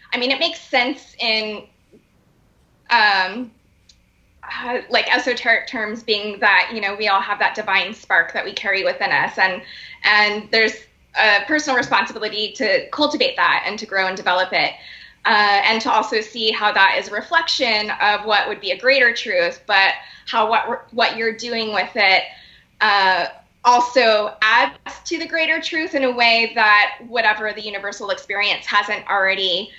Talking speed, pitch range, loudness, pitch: 165 wpm, 200-245 Hz, -17 LUFS, 215 Hz